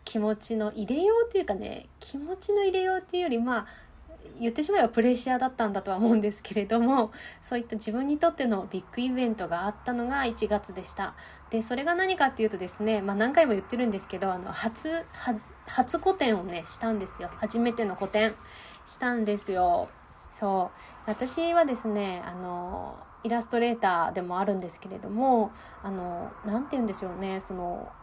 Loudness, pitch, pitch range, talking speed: -29 LUFS, 225 Hz, 200-255 Hz, 365 characters per minute